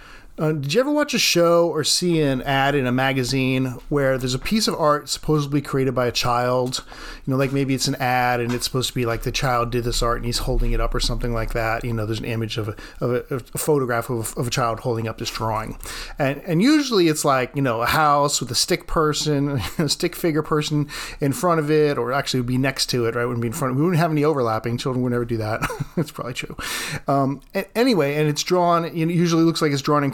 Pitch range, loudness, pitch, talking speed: 120-155 Hz, -21 LUFS, 135 Hz, 270 wpm